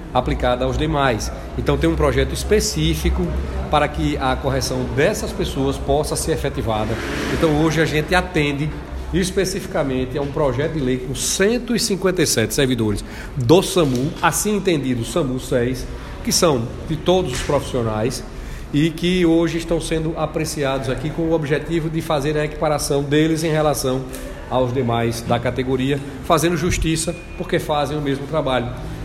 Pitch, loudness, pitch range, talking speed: 150 Hz, -20 LUFS, 130-165 Hz, 145 wpm